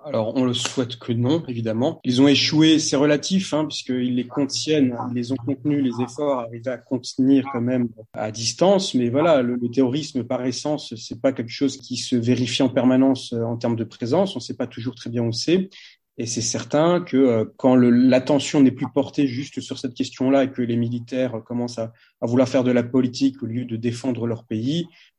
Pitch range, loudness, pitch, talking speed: 120-140 Hz, -21 LUFS, 130 Hz, 215 wpm